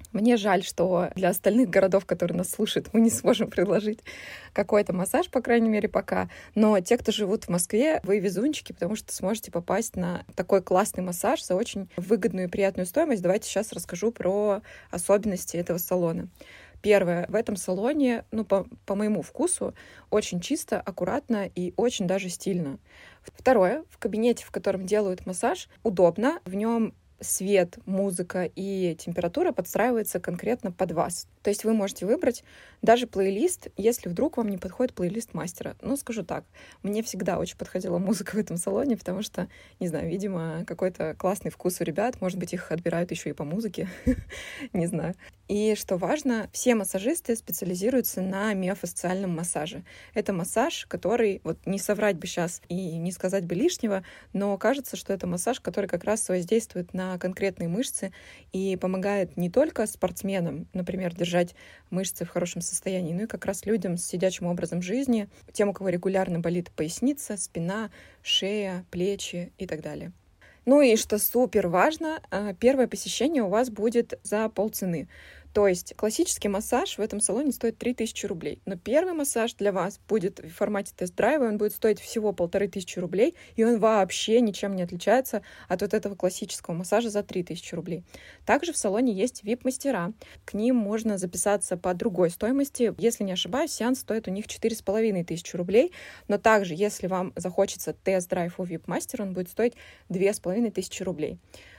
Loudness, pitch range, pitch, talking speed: -27 LUFS, 180-225 Hz, 195 Hz, 165 wpm